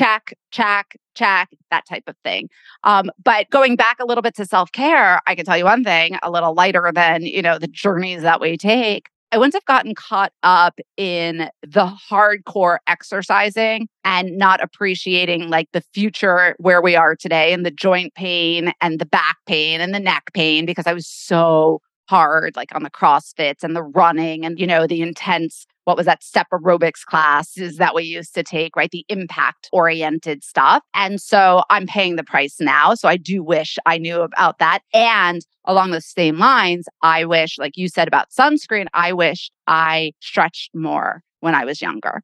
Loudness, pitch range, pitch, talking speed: -16 LUFS, 165-200 Hz, 175 Hz, 190 wpm